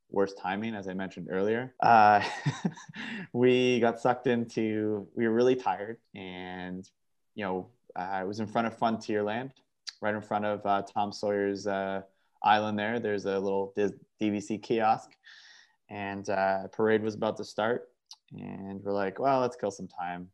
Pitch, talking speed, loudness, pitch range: 105 Hz, 160 wpm, -29 LUFS, 95-115 Hz